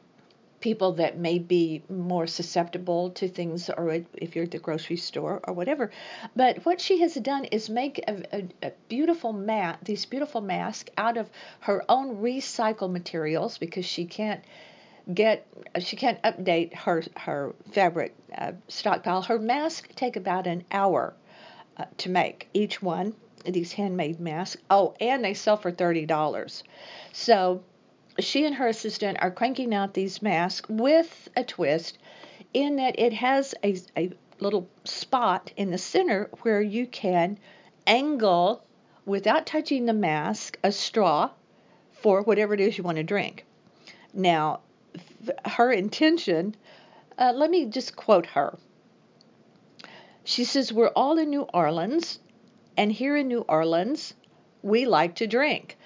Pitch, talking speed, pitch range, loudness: 205 Hz, 150 wpm, 180-245 Hz, -26 LUFS